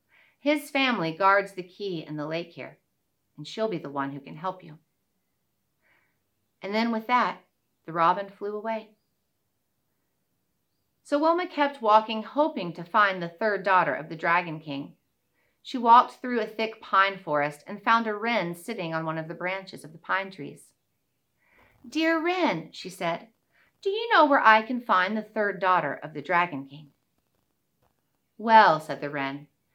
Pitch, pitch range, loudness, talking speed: 195 Hz, 160-225 Hz, -25 LUFS, 165 wpm